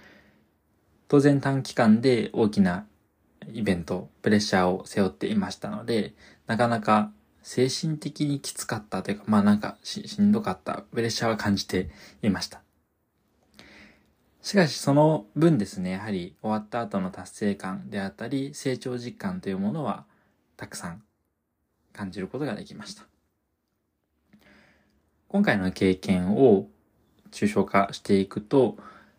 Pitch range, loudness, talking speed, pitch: 100-145 Hz, -26 LUFS, 285 characters per minute, 115 Hz